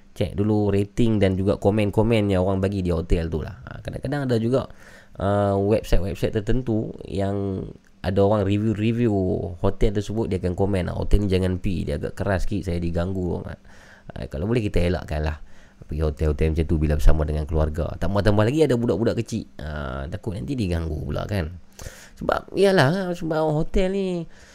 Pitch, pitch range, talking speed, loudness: 100 Hz, 85-110 Hz, 175 wpm, -24 LUFS